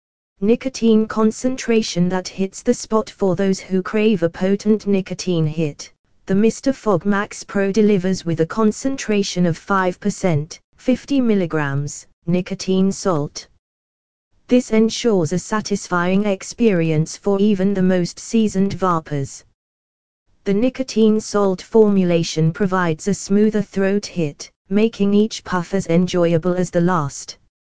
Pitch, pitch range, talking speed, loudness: 195 Hz, 175-215 Hz, 120 wpm, -19 LUFS